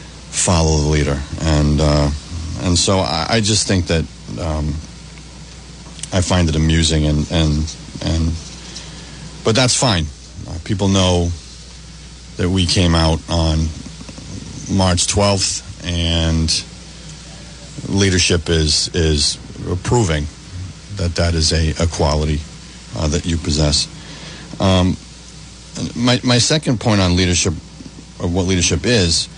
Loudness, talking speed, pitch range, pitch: -16 LUFS, 120 wpm, 80-95 Hz, 85 Hz